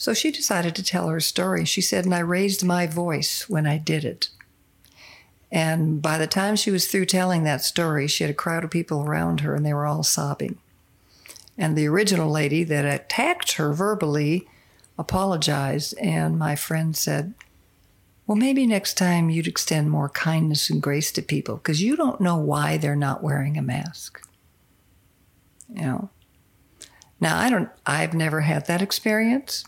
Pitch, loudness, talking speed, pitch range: 160 Hz, -23 LUFS, 175 wpm, 145-180 Hz